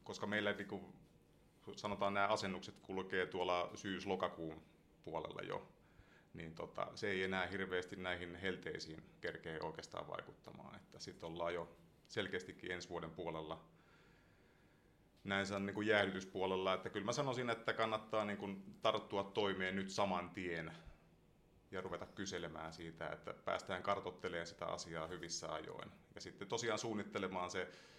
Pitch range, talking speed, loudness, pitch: 85-100 Hz, 135 wpm, -43 LUFS, 95 Hz